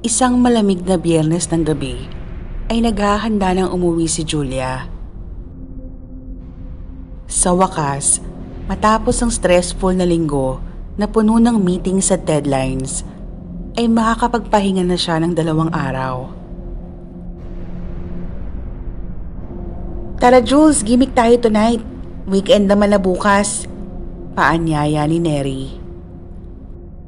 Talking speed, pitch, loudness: 100 wpm, 165 Hz, -16 LUFS